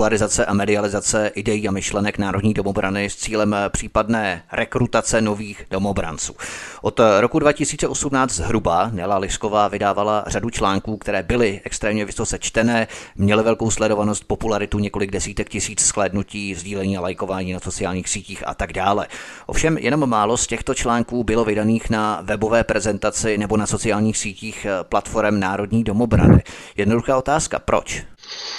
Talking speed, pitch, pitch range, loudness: 135 wpm, 105 Hz, 100-115 Hz, -20 LUFS